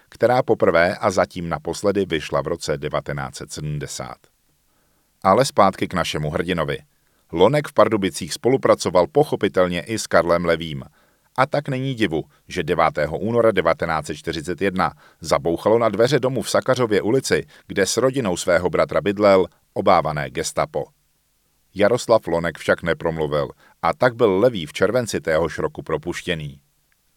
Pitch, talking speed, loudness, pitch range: 90 Hz, 130 wpm, -20 LUFS, 85-105 Hz